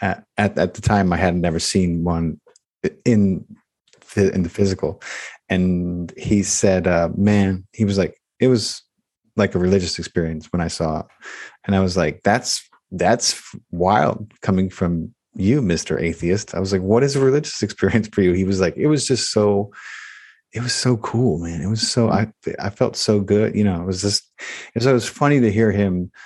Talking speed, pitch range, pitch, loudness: 200 wpm, 90-110 Hz, 100 Hz, -19 LUFS